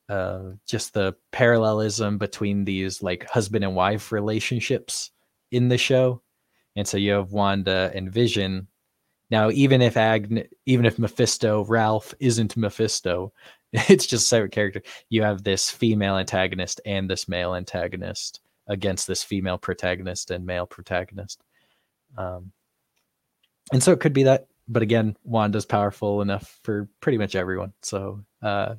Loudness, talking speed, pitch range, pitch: -23 LUFS, 145 wpm, 95-115 Hz, 105 Hz